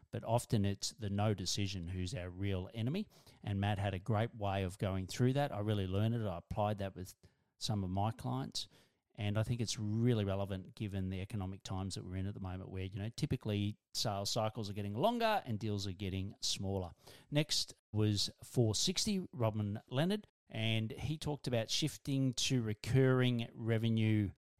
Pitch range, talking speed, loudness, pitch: 100-120 Hz, 185 wpm, -37 LUFS, 105 Hz